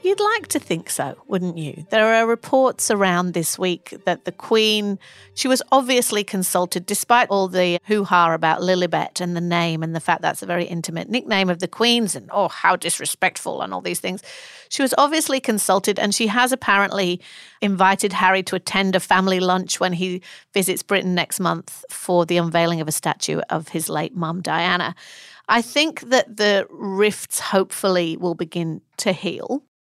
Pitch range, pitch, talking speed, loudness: 175-220 Hz, 190 Hz, 185 wpm, -20 LUFS